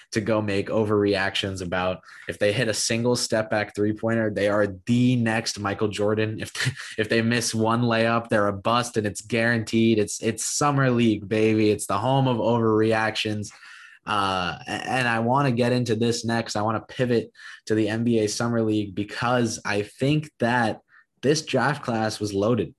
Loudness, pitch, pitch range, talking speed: -23 LUFS, 110 Hz, 105-120 Hz, 180 wpm